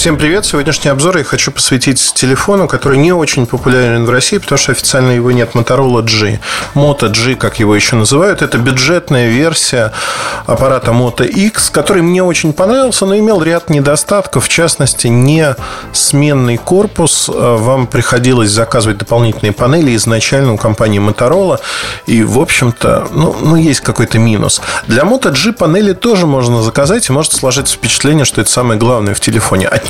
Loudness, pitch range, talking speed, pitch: -9 LUFS, 120-155 Hz, 160 wpm, 130 Hz